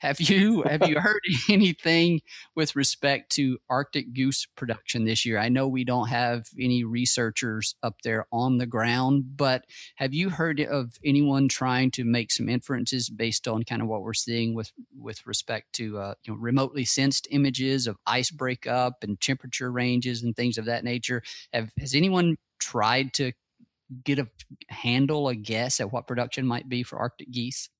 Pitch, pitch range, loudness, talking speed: 125 Hz, 120-140 Hz, -26 LUFS, 180 wpm